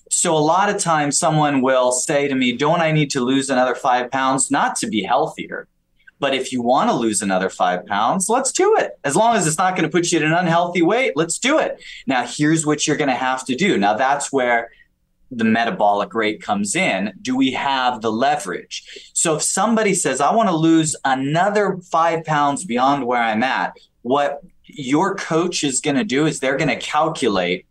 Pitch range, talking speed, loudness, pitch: 130-175 Hz, 215 wpm, -18 LUFS, 150 Hz